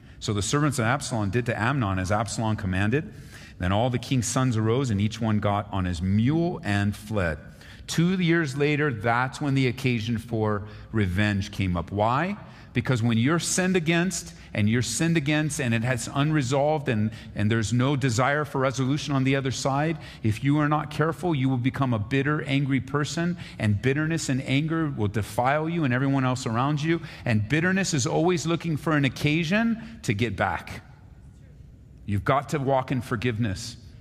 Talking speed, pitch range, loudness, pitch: 180 wpm, 110-150 Hz, -25 LUFS, 130 Hz